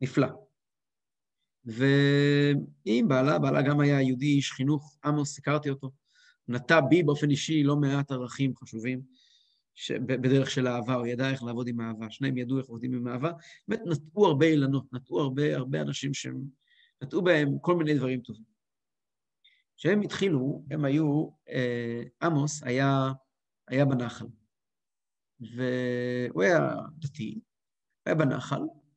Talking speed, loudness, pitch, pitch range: 135 wpm, -28 LUFS, 135 Hz, 125-145 Hz